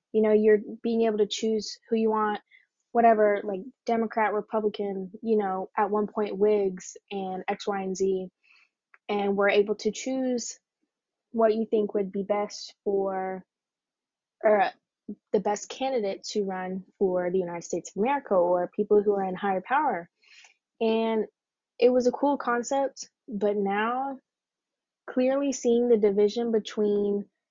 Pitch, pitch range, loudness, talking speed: 210 Hz, 200-230 Hz, -27 LUFS, 150 wpm